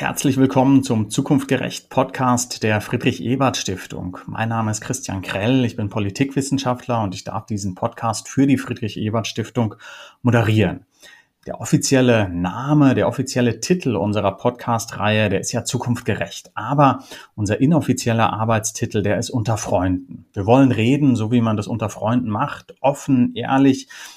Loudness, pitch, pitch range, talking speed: -19 LUFS, 120 Hz, 110-130 Hz, 140 wpm